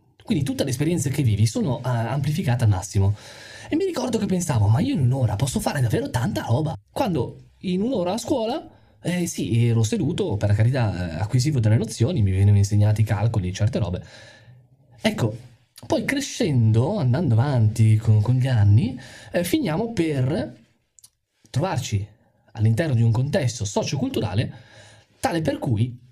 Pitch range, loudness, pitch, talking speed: 110-135 Hz, -22 LUFS, 120 Hz, 155 wpm